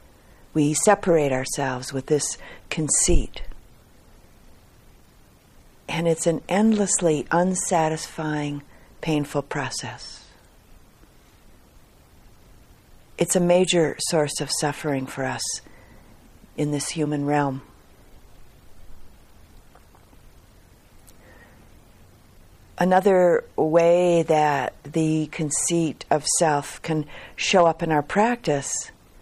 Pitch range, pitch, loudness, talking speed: 125-170 Hz, 150 Hz, -22 LUFS, 80 wpm